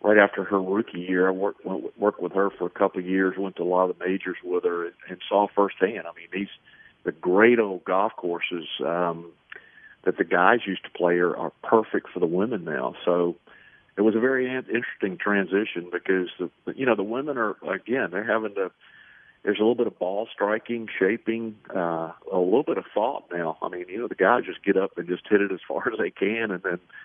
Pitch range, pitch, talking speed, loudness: 90-105 Hz, 95 Hz, 230 wpm, -25 LUFS